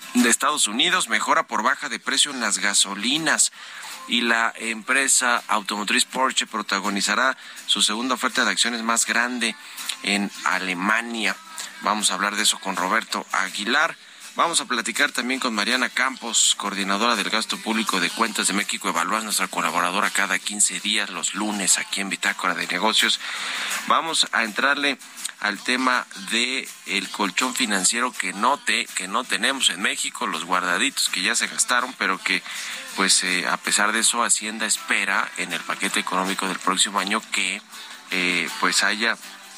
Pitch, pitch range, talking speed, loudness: 105 Hz, 95-115 Hz, 160 wpm, -21 LUFS